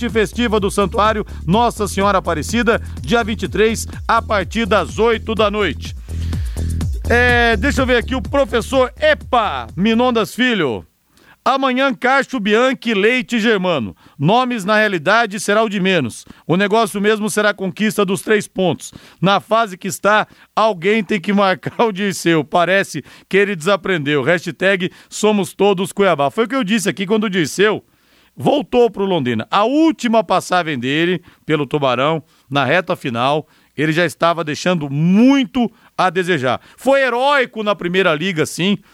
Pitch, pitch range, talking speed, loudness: 200 Hz, 170-230 Hz, 150 wpm, -16 LUFS